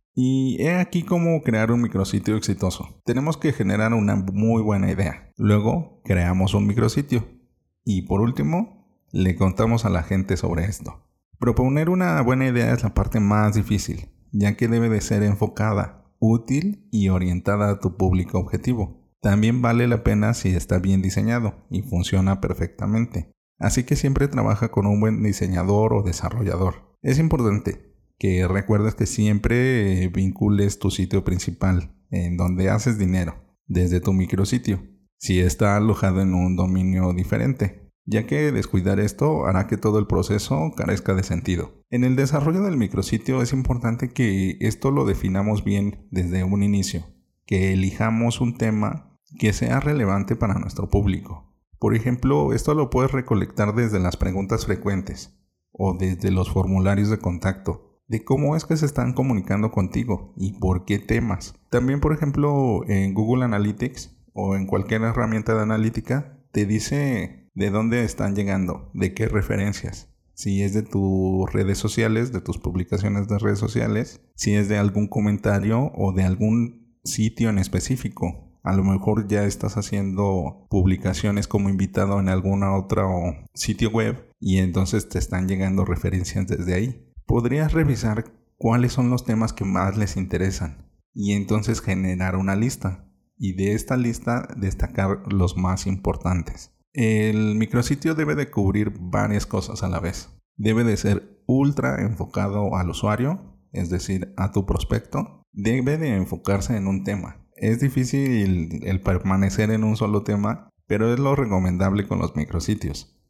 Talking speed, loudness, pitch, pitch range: 155 wpm, -22 LUFS, 105 Hz, 95-115 Hz